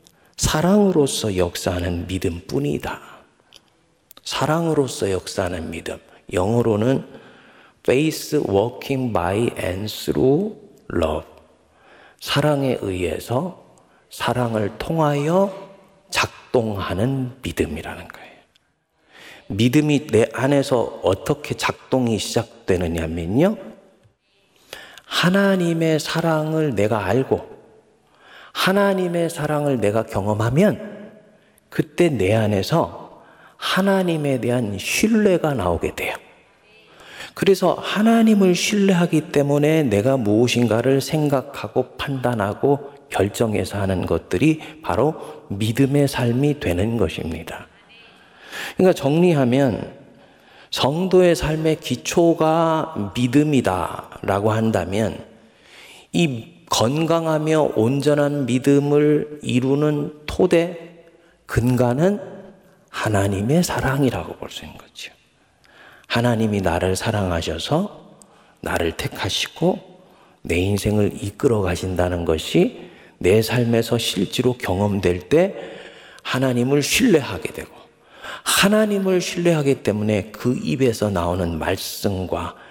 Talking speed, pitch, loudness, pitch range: 235 characters per minute, 130 Hz, -20 LUFS, 105-160 Hz